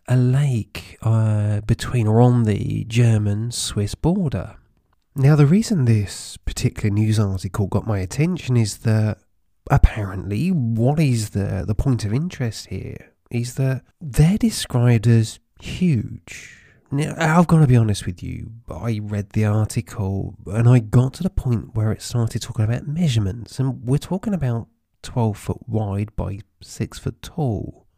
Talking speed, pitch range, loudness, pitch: 155 wpm, 105-130 Hz, -21 LUFS, 115 Hz